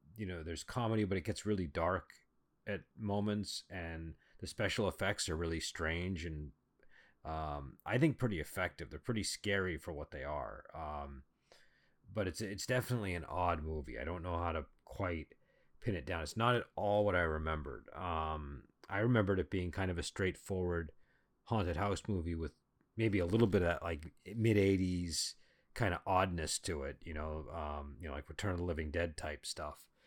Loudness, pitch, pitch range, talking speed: -38 LUFS, 85 Hz, 80-100 Hz, 190 wpm